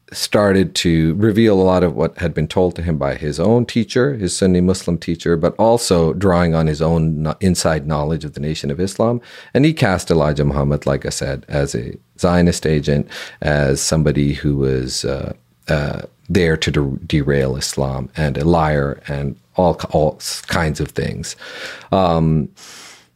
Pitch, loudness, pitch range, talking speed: 80 Hz, -17 LUFS, 75-90 Hz, 170 wpm